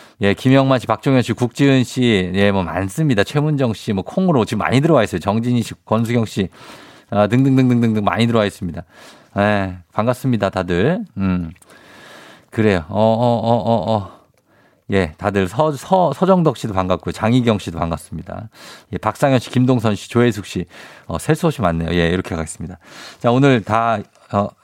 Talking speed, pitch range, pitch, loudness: 325 characters per minute, 95-125 Hz, 110 Hz, -17 LUFS